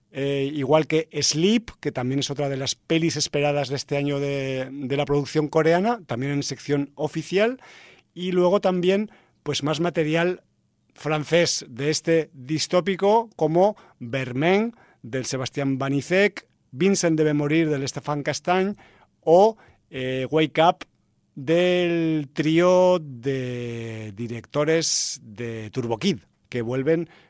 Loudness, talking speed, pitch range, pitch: -23 LUFS, 125 wpm, 135-175 Hz, 150 Hz